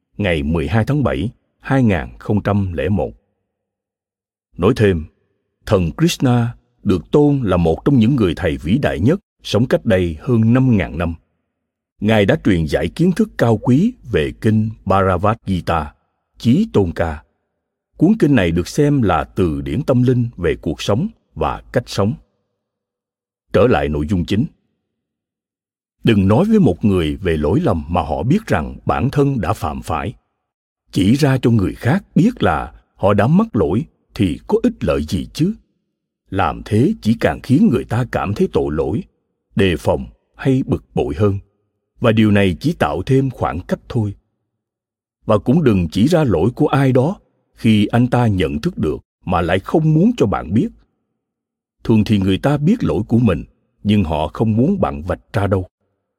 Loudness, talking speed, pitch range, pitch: -17 LUFS, 170 wpm, 95-125 Hz, 110 Hz